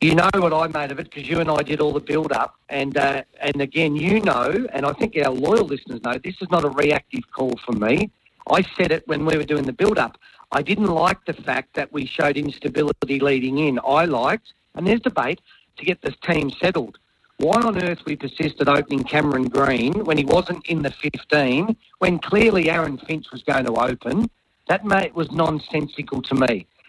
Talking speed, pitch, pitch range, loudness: 215 wpm, 150 Hz, 140-170 Hz, -21 LUFS